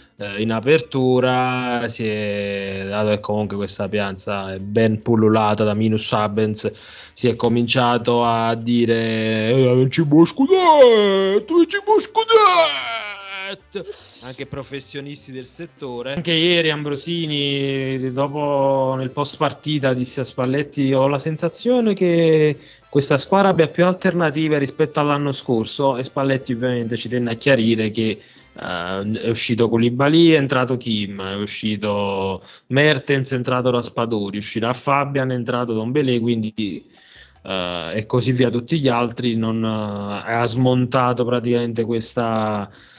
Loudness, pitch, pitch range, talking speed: -19 LUFS, 125 Hz, 110-145 Hz, 130 wpm